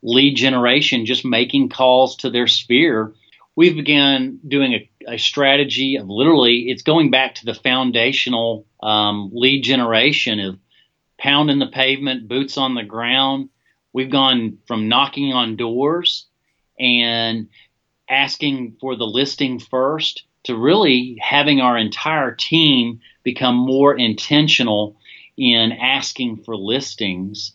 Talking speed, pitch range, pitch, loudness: 125 wpm, 115-140 Hz, 130 Hz, -16 LUFS